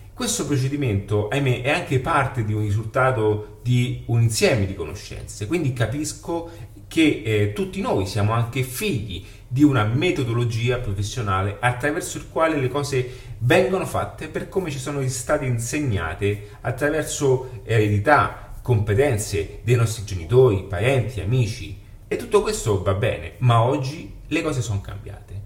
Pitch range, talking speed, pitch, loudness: 105-135 Hz, 140 wpm, 120 Hz, -22 LUFS